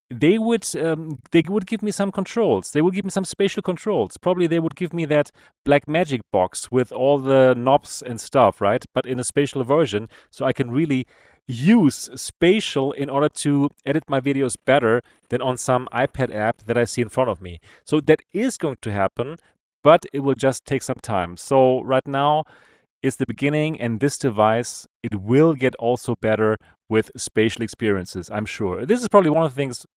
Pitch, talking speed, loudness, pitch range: 135 Hz, 200 wpm, -21 LUFS, 120-155 Hz